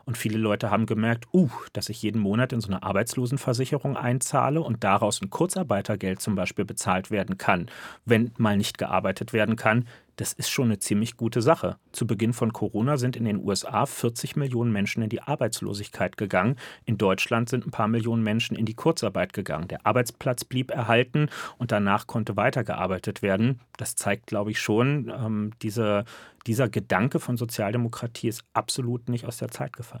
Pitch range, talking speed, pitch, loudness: 105-125 Hz, 180 wpm, 115 Hz, -26 LUFS